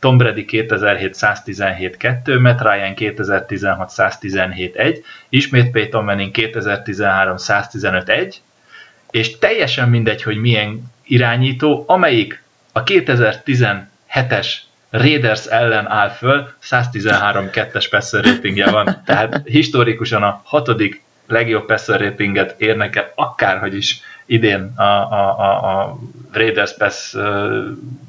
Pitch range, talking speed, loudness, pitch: 105-125 Hz, 90 wpm, -16 LUFS, 115 Hz